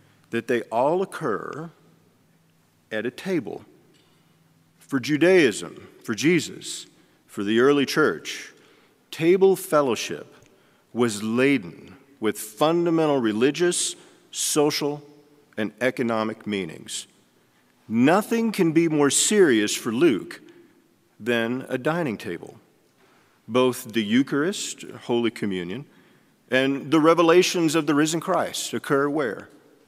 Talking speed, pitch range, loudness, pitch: 100 wpm, 120-175 Hz, -23 LUFS, 145 Hz